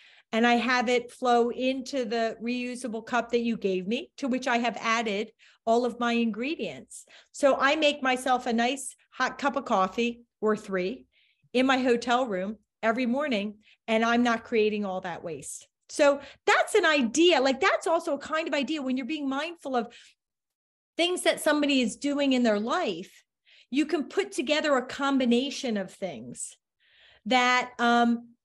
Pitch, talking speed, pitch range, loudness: 245 Hz, 170 wpm, 230-280 Hz, -26 LUFS